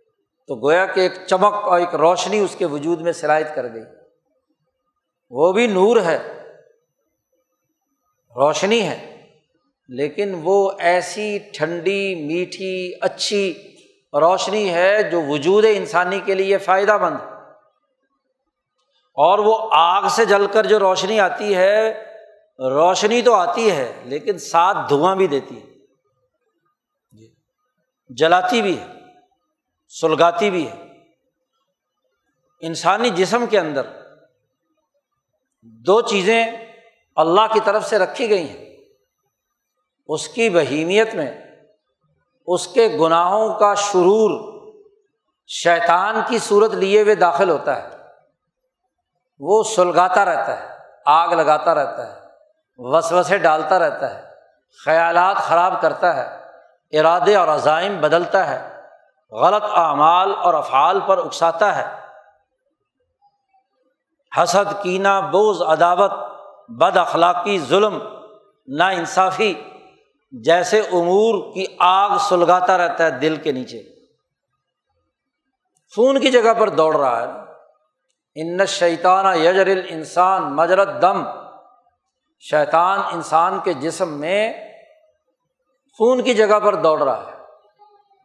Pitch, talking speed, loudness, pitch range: 200 Hz, 115 wpm, -17 LUFS, 175-245 Hz